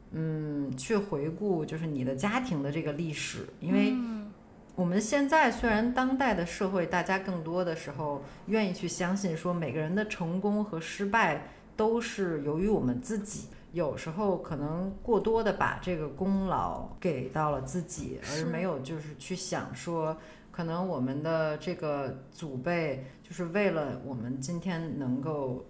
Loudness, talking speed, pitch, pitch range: -31 LUFS, 240 characters per minute, 175 Hz, 150-200 Hz